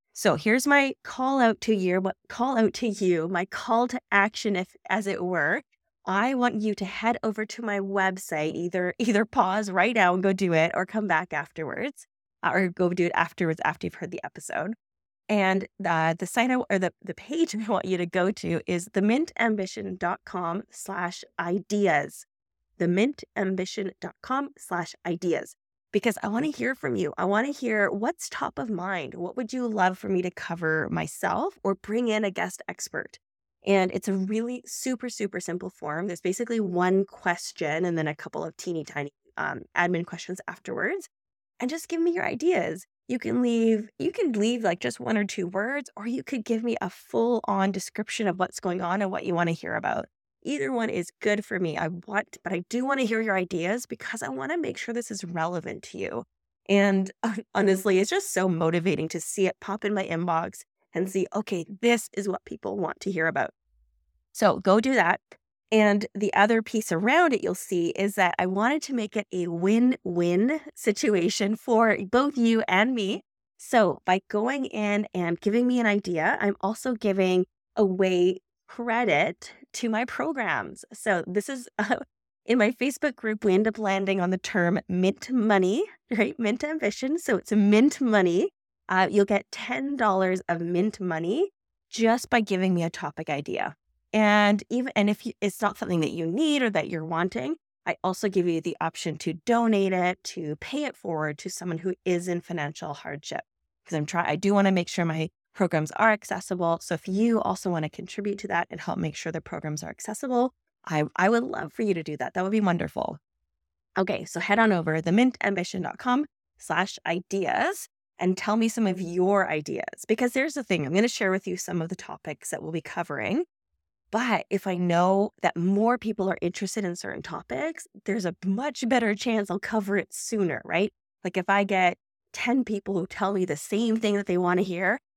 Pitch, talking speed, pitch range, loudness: 200 Hz, 200 wpm, 180-225 Hz, -26 LUFS